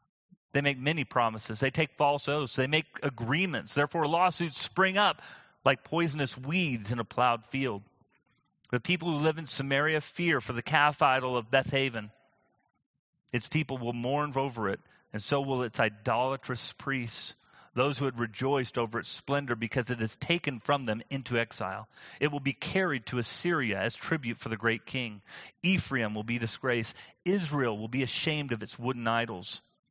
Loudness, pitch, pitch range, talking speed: -30 LUFS, 135 Hz, 120-150 Hz, 175 wpm